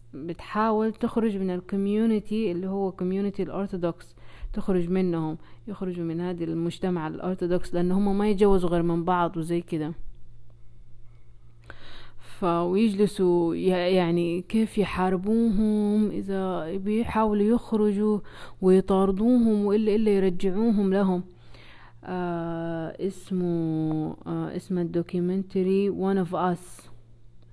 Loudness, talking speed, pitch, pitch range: -26 LUFS, 95 wpm, 185 Hz, 165-200 Hz